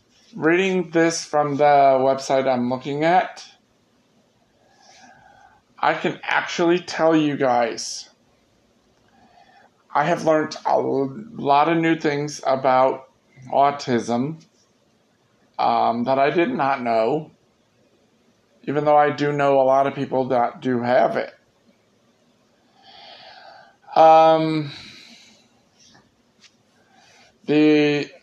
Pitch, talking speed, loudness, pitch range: 145 Hz, 95 wpm, -19 LUFS, 135-160 Hz